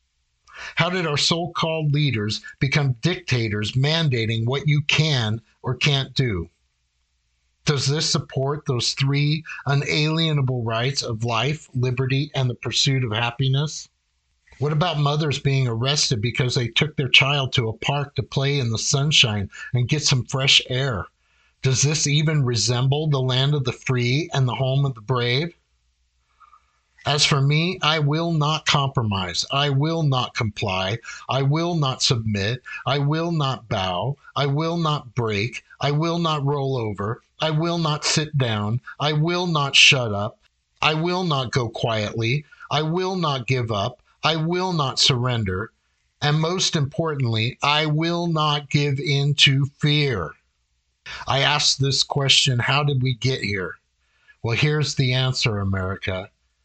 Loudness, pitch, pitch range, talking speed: -21 LUFS, 135 Hz, 115-150 Hz, 155 wpm